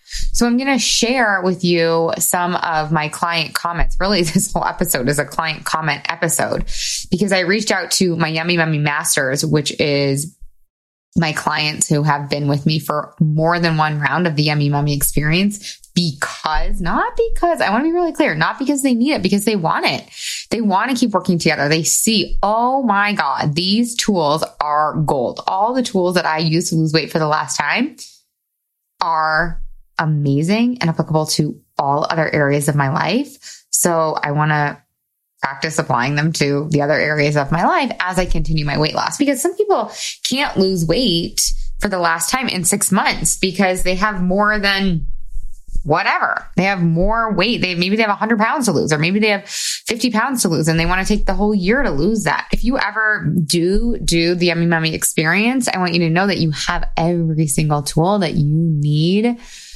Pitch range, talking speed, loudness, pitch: 155-210 Hz, 200 wpm, -17 LUFS, 175 Hz